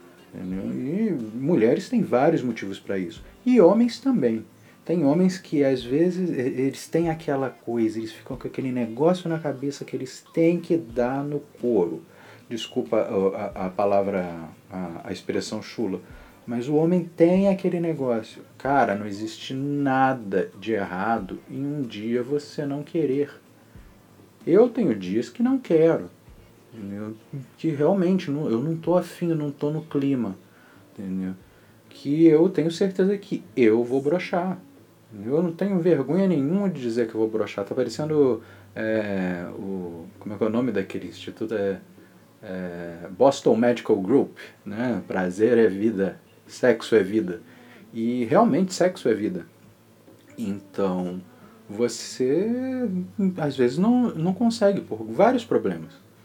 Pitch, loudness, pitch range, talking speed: 130 Hz, -24 LUFS, 110-165 Hz, 145 wpm